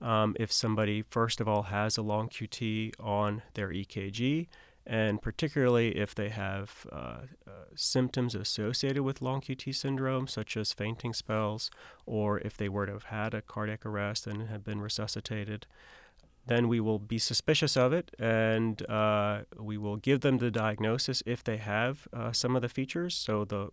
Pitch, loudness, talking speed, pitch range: 110 Hz, -32 LUFS, 175 wpm, 105-125 Hz